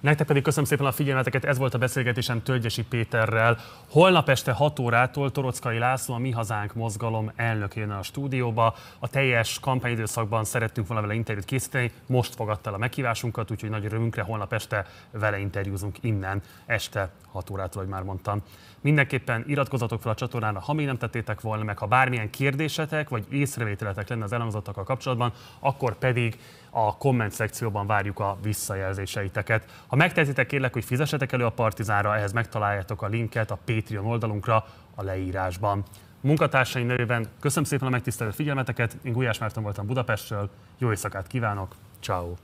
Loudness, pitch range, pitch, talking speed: -26 LUFS, 105-130 Hz, 115 Hz, 160 wpm